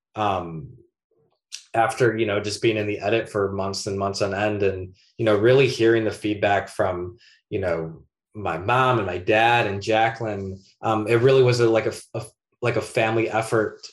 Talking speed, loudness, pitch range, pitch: 190 wpm, -22 LUFS, 100-115 Hz, 110 Hz